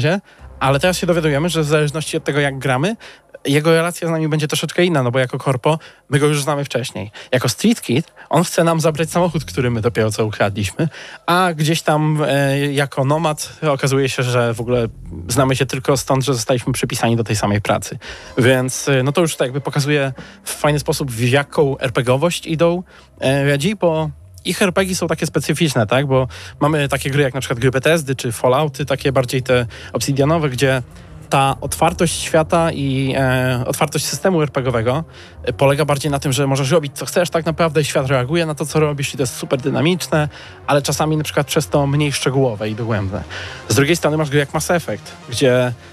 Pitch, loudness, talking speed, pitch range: 145 Hz, -17 LUFS, 195 wpm, 130-160 Hz